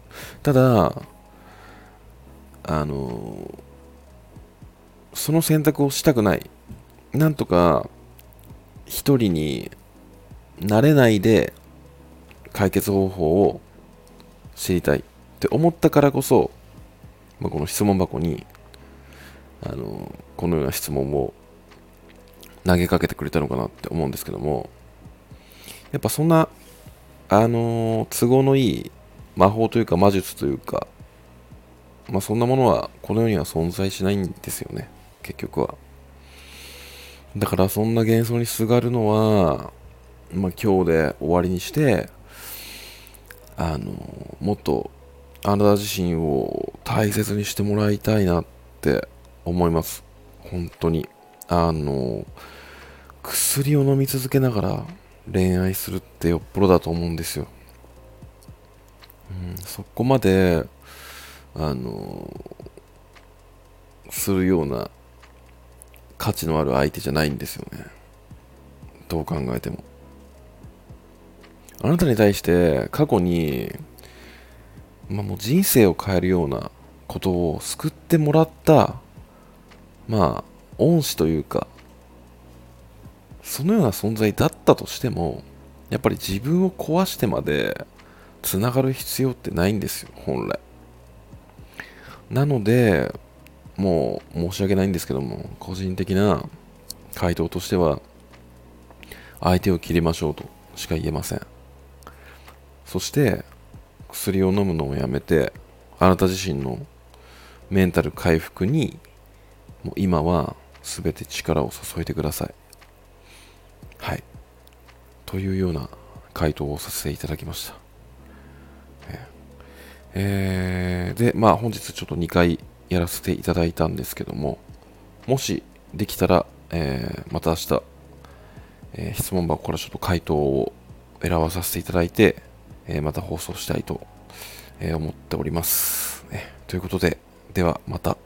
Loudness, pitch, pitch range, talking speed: -22 LUFS, 85 Hz, 70-105 Hz, 230 characters per minute